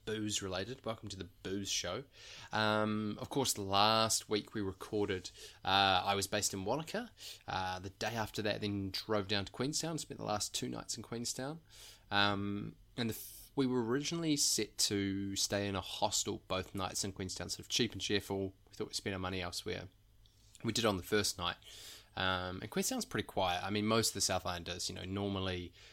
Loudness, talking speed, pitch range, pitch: -36 LUFS, 200 wpm, 95-110 Hz, 105 Hz